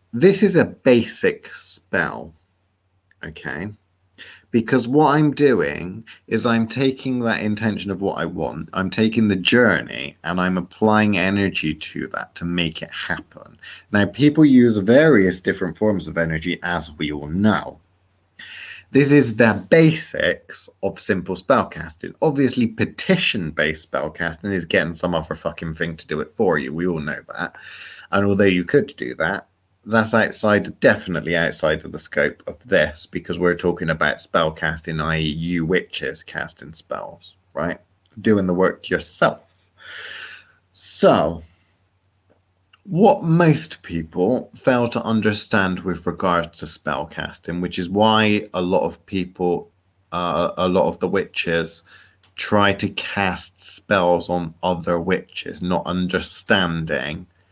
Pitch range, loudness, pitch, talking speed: 85-110 Hz, -20 LUFS, 95 Hz, 145 wpm